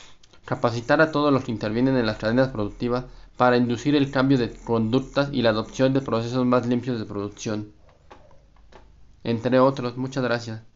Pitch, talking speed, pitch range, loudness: 125 Hz, 160 wpm, 115-130 Hz, -23 LUFS